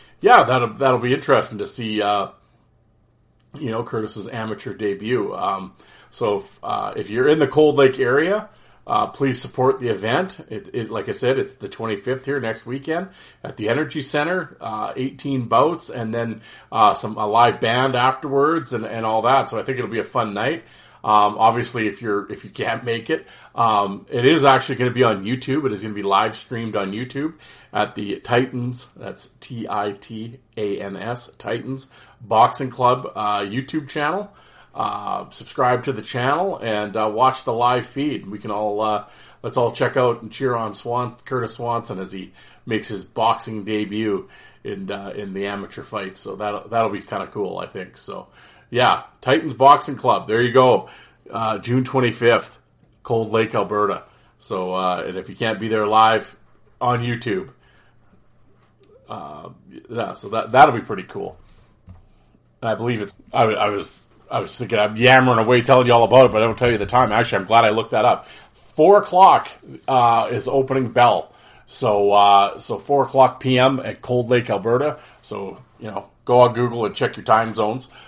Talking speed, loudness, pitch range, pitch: 190 wpm, -19 LUFS, 110-130 Hz, 120 Hz